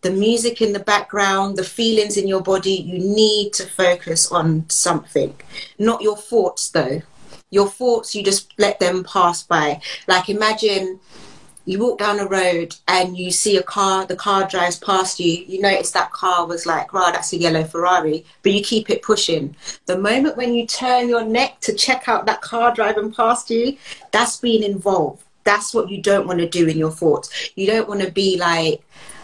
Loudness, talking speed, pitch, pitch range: -18 LUFS, 195 wpm, 195 Hz, 180-215 Hz